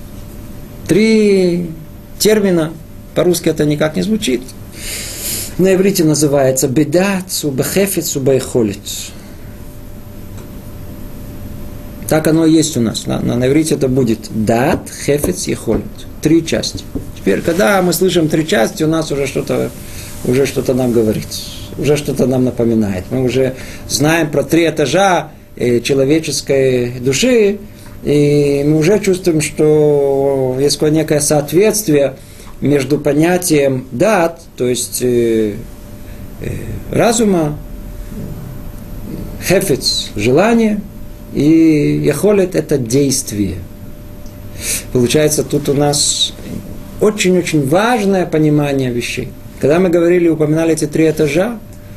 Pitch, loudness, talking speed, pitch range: 140 Hz, -14 LUFS, 105 wpm, 115-160 Hz